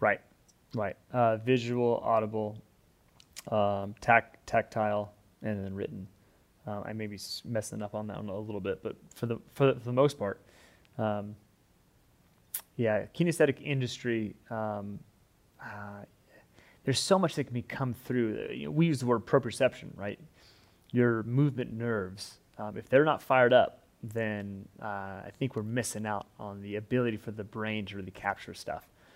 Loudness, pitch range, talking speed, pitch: -31 LUFS, 100-120 Hz, 165 wpm, 110 Hz